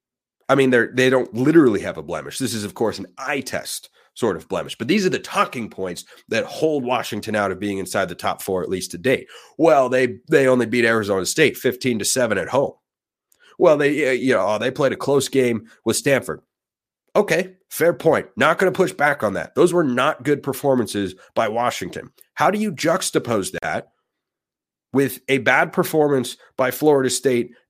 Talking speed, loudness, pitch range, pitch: 195 wpm, -20 LUFS, 120-145 Hz, 130 Hz